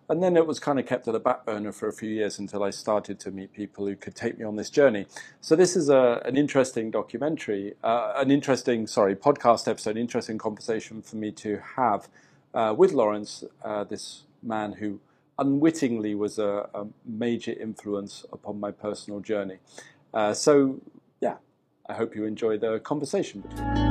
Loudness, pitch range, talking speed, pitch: -26 LUFS, 105-125 Hz, 185 wpm, 110 Hz